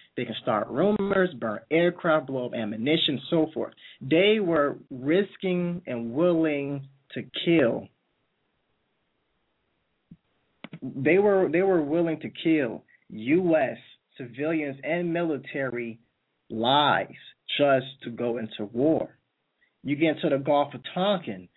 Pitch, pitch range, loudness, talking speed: 150 Hz, 125-170 Hz, -25 LUFS, 115 wpm